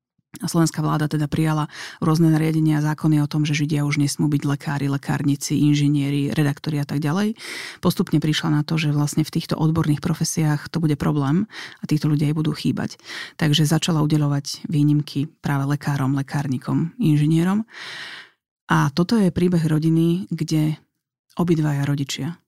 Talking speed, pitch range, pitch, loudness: 155 wpm, 145-160 Hz, 155 Hz, -21 LUFS